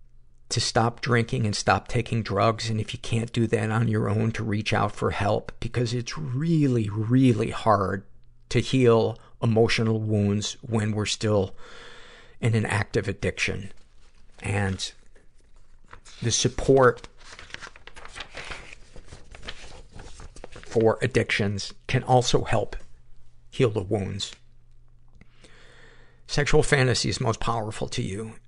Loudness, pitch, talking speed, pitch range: -25 LUFS, 110 Hz, 115 wpm, 100-120 Hz